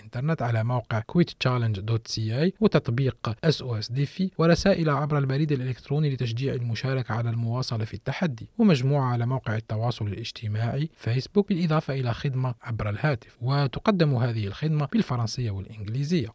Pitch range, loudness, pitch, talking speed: 115-150 Hz, -26 LUFS, 130 Hz, 115 wpm